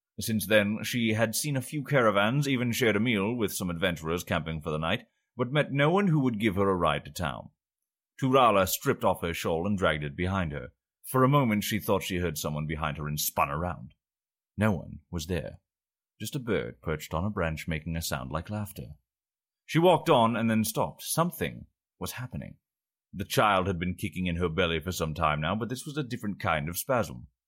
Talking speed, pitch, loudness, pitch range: 215 wpm, 95 Hz, -28 LUFS, 80-115 Hz